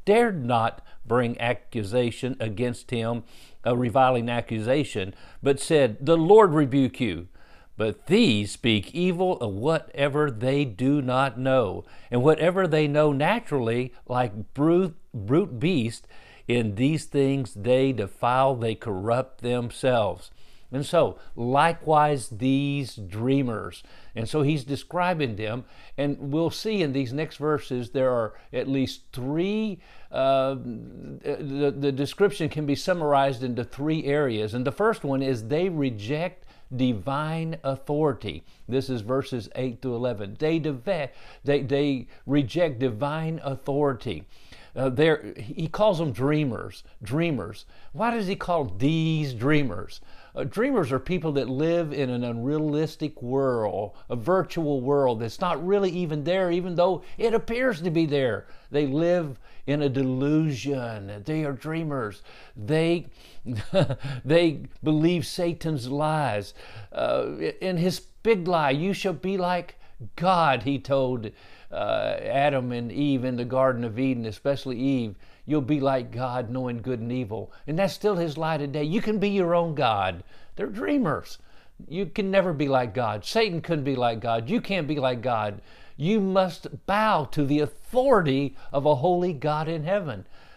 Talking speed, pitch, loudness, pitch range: 145 wpm, 140 Hz, -25 LUFS, 125-160 Hz